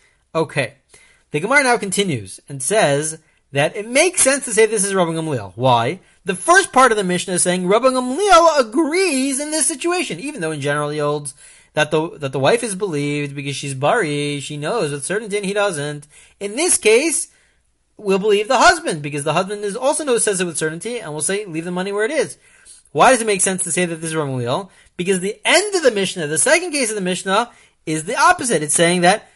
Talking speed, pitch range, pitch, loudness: 225 wpm, 155-255 Hz, 195 Hz, -17 LUFS